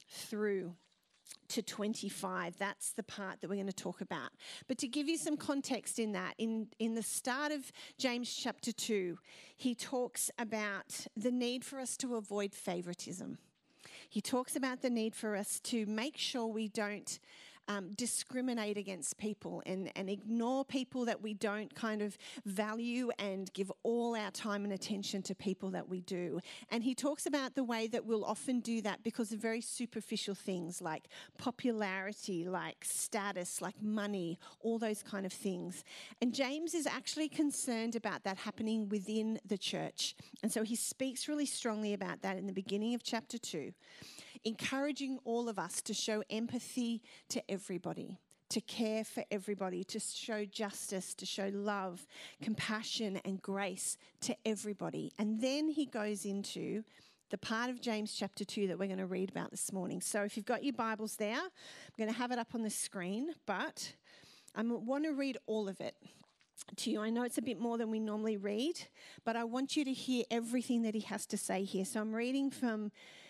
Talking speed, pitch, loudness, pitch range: 185 wpm, 220 Hz, -39 LUFS, 200-245 Hz